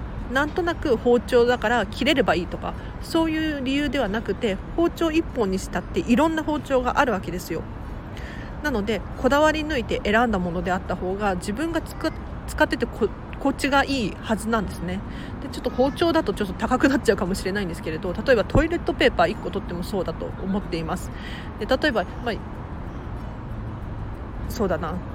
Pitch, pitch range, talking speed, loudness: 250 Hz, 210-305 Hz, 380 characters per minute, -24 LUFS